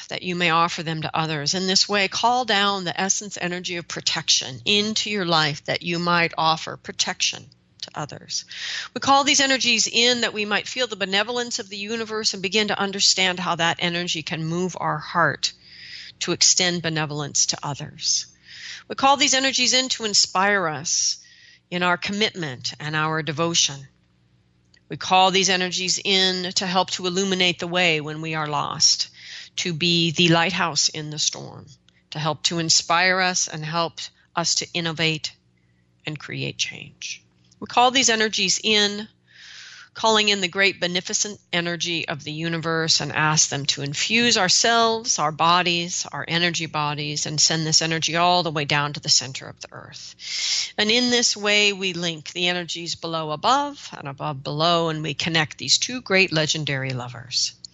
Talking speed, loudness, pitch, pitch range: 175 wpm, -20 LUFS, 170 Hz, 155-200 Hz